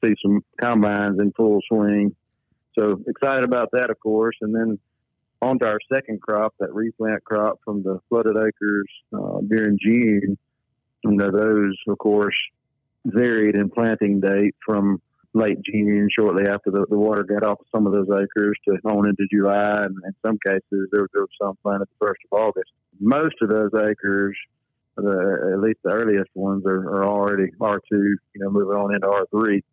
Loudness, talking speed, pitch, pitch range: -21 LUFS, 180 wpm, 105 Hz, 100-110 Hz